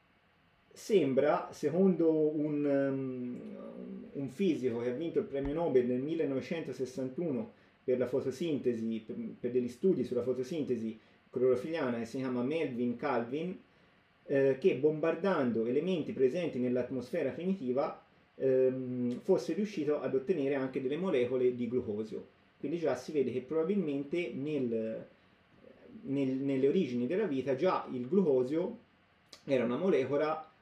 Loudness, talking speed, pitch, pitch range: -33 LUFS, 125 wpm, 135 Hz, 125-160 Hz